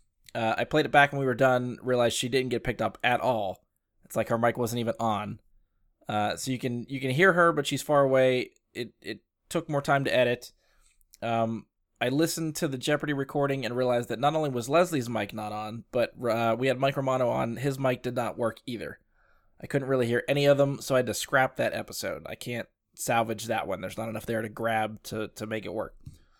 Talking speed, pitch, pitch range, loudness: 235 wpm, 125 Hz, 115-140 Hz, -28 LUFS